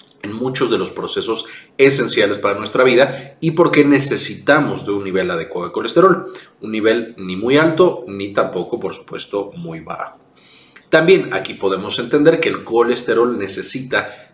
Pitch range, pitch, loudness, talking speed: 100-140 Hz, 120 Hz, -16 LUFS, 155 wpm